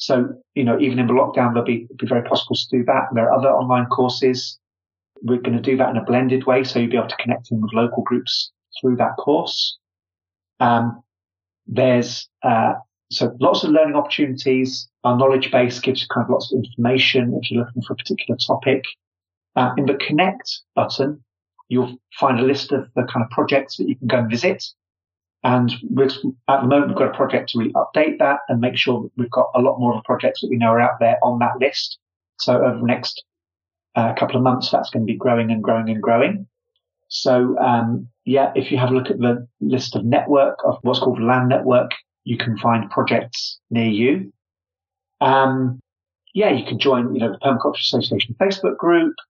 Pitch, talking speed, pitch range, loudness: 125 Hz, 210 wpm, 115-130 Hz, -19 LUFS